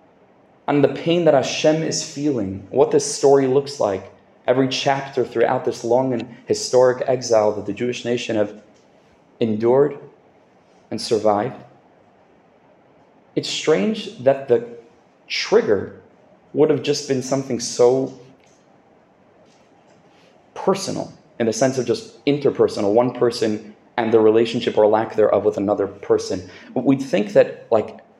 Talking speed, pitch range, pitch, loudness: 130 wpm, 115-140 Hz, 125 Hz, -20 LUFS